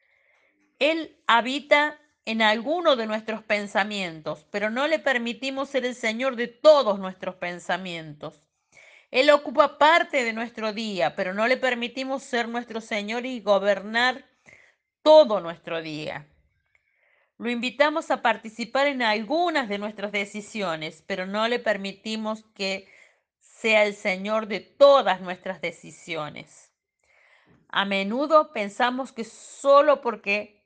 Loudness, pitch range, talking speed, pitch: -24 LUFS, 200-270 Hz, 125 wpm, 225 Hz